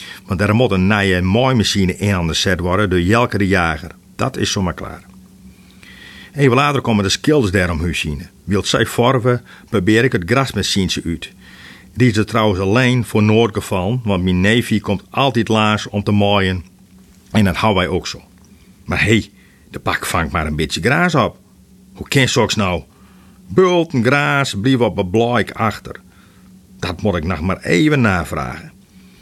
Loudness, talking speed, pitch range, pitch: -16 LUFS, 185 wpm, 95-115 Hz, 100 Hz